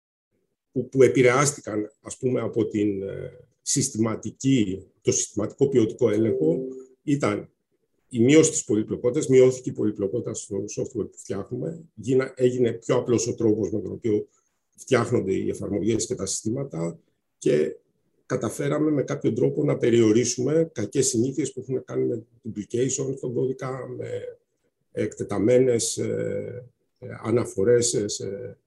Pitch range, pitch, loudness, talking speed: 110-130 Hz, 125 Hz, -24 LUFS, 115 wpm